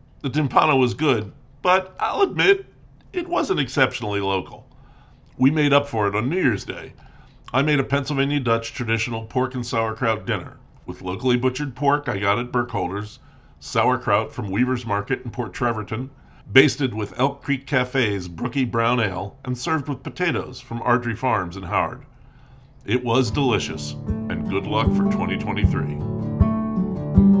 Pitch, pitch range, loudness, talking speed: 130 Hz, 115-140 Hz, -22 LUFS, 155 wpm